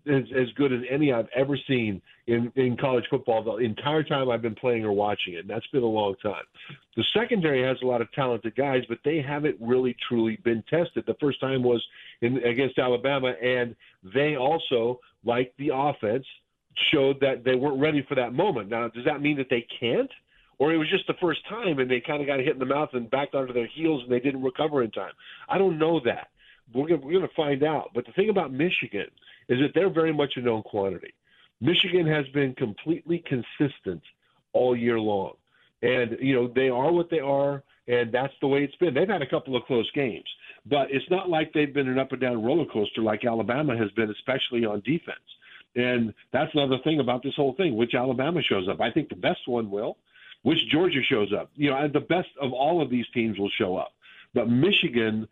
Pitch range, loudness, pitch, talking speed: 120-150 Hz, -26 LUFS, 130 Hz, 220 wpm